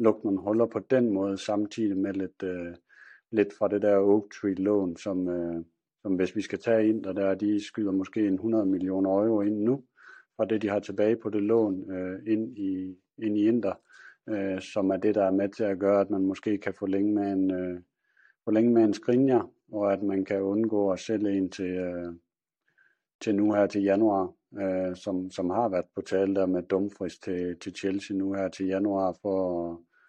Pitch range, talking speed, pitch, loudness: 95-105 Hz, 210 wpm, 100 Hz, -28 LUFS